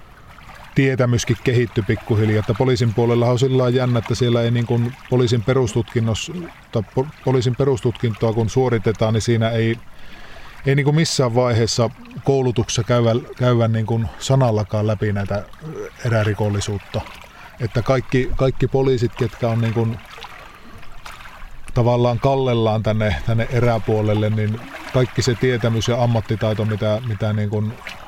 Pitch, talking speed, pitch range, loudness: 120 Hz, 115 wpm, 110-130 Hz, -19 LUFS